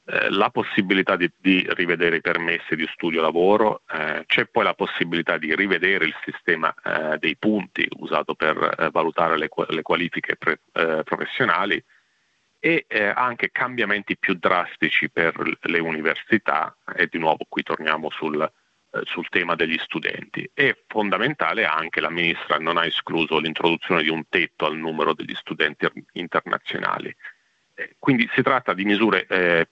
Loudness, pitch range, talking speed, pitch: -22 LUFS, 80-105 Hz, 150 wpm, 90 Hz